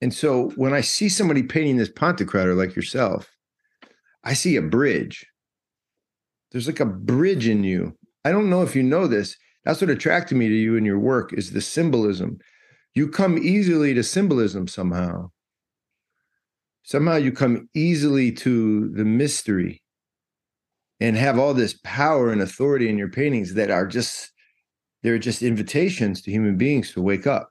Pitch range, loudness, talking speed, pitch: 105-145 Hz, -21 LUFS, 165 wpm, 125 Hz